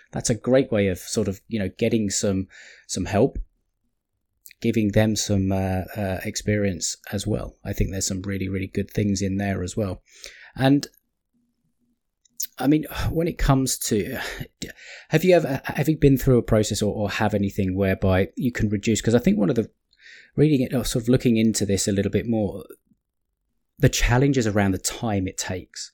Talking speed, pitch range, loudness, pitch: 190 wpm, 100-125 Hz, -23 LUFS, 105 Hz